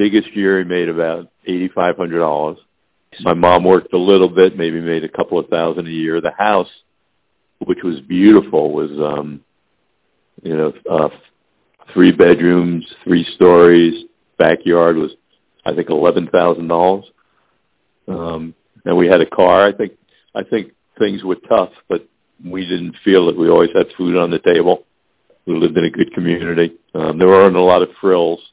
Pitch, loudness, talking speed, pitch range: 85 Hz, -14 LUFS, 170 wpm, 85-90 Hz